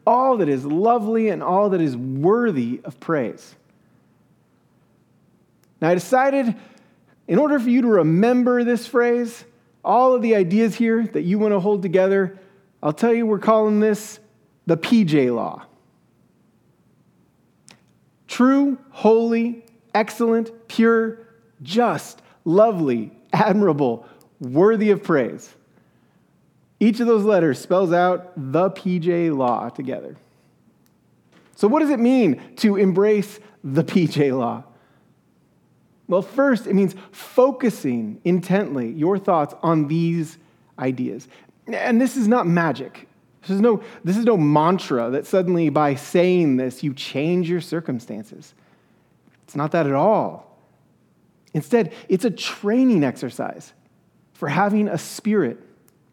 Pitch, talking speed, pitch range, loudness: 200 Hz, 125 wpm, 165-230 Hz, -20 LUFS